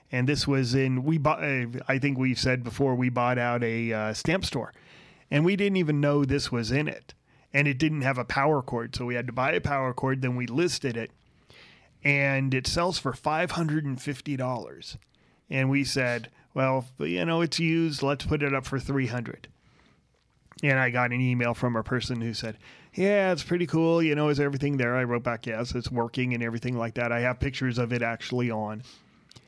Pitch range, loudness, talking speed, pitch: 120-145 Hz, -27 LUFS, 220 wpm, 130 Hz